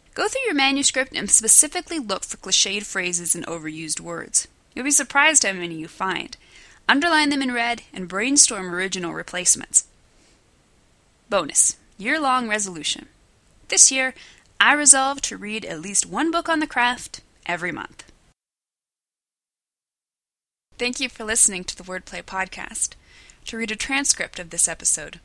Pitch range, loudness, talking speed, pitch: 185-275 Hz, -19 LUFS, 145 wpm, 220 Hz